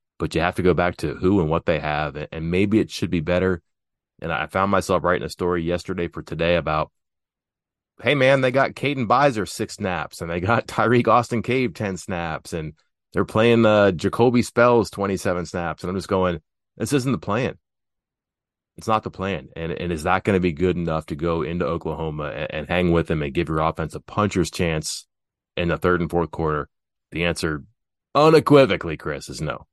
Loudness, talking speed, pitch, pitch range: -22 LUFS, 205 wpm, 90 Hz, 80-110 Hz